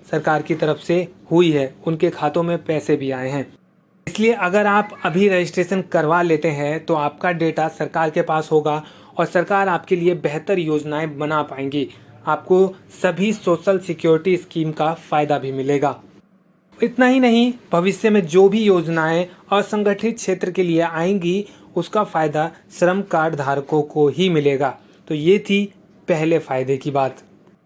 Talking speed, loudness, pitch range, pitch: 160 wpm, -19 LUFS, 155-190 Hz, 170 Hz